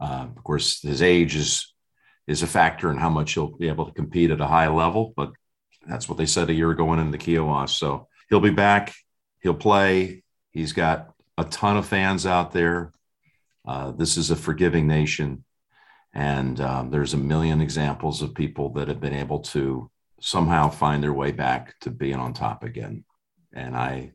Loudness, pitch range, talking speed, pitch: -23 LUFS, 70-85 Hz, 190 wpm, 80 Hz